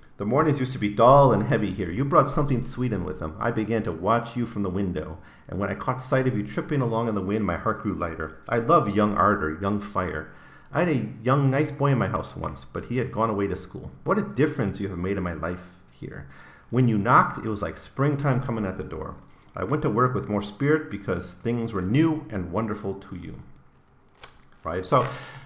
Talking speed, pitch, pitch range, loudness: 240 wpm, 105 Hz, 95-125 Hz, -25 LUFS